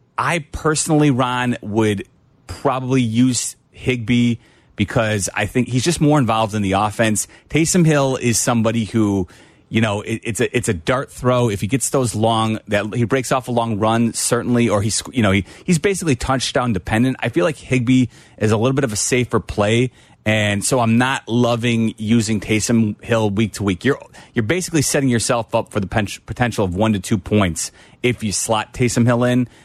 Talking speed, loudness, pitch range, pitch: 195 wpm, -18 LUFS, 110-130 Hz, 115 Hz